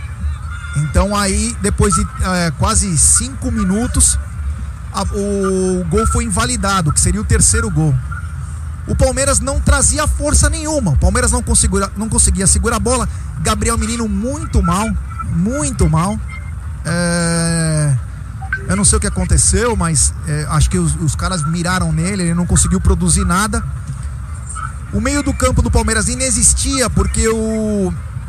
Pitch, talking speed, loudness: 115 Hz, 150 wpm, -15 LUFS